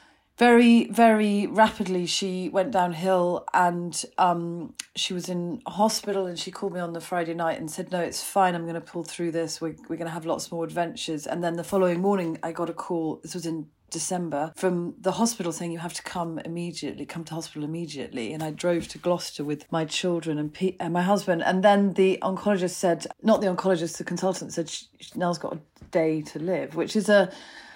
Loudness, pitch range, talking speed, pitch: -26 LUFS, 165-190 Hz, 215 wpm, 175 Hz